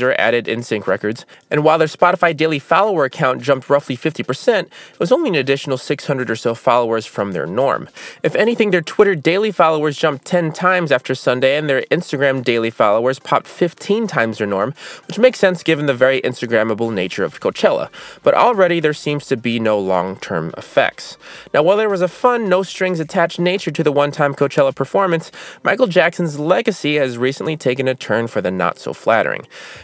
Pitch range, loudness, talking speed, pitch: 130-180 Hz, -17 LUFS, 195 wpm, 150 Hz